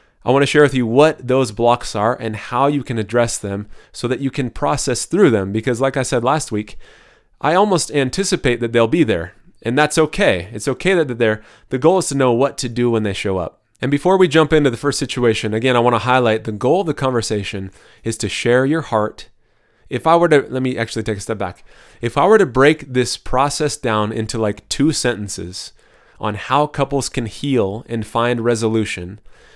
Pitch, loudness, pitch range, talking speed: 120 Hz, -17 LUFS, 110-140 Hz, 220 wpm